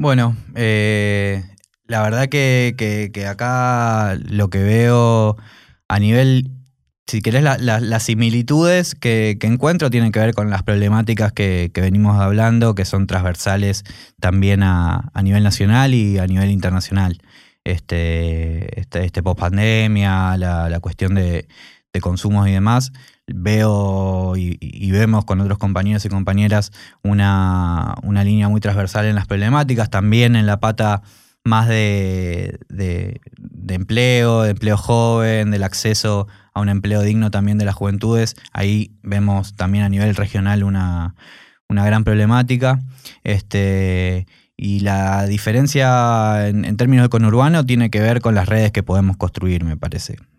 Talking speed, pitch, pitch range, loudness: 150 wpm, 105 Hz, 95-115 Hz, -17 LUFS